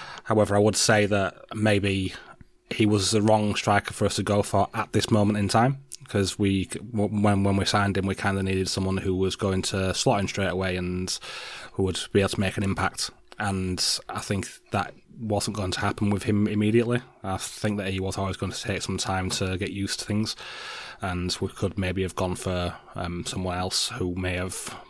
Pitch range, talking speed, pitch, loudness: 95-105 Hz, 215 wpm, 100 Hz, -26 LUFS